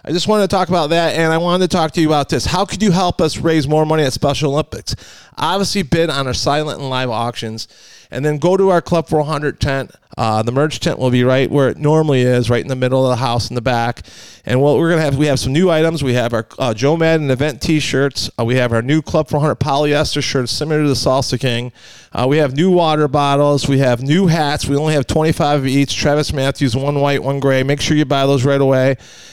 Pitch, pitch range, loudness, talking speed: 145 Hz, 130-155 Hz, -15 LUFS, 260 wpm